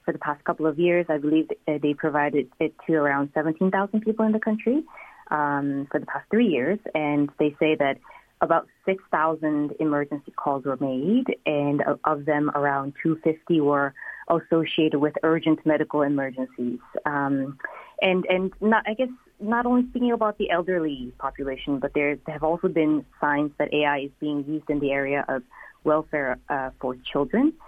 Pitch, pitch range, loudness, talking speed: 155 Hz, 145-175 Hz, -24 LUFS, 165 wpm